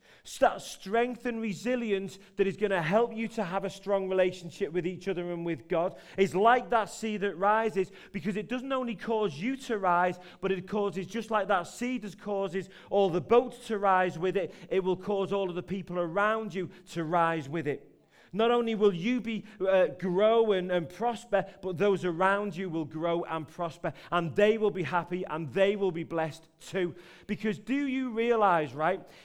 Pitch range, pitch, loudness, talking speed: 180-215 Hz, 195 Hz, -30 LUFS, 200 wpm